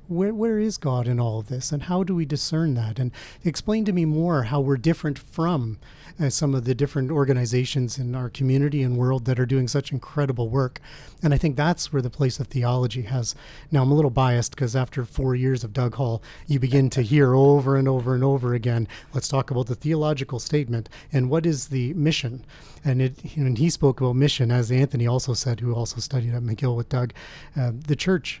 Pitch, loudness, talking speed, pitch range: 135 Hz, -23 LUFS, 220 wpm, 125-150 Hz